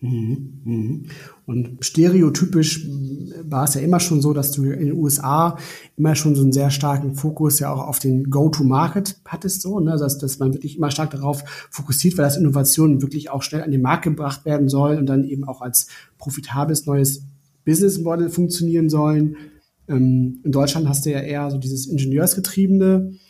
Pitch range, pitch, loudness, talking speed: 140-160 Hz, 145 Hz, -19 LUFS, 175 wpm